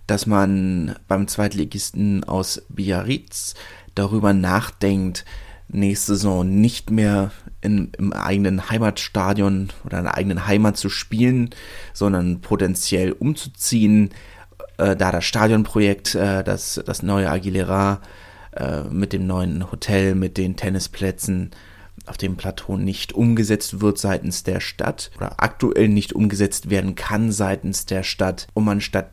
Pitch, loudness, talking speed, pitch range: 100 Hz, -21 LUFS, 130 wpm, 95-105 Hz